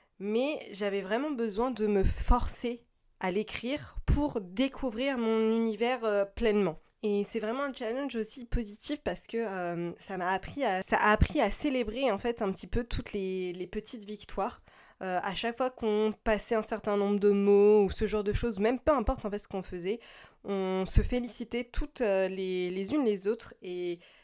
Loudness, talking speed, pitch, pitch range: -31 LUFS, 190 wpm, 215 Hz, 200-240 Hz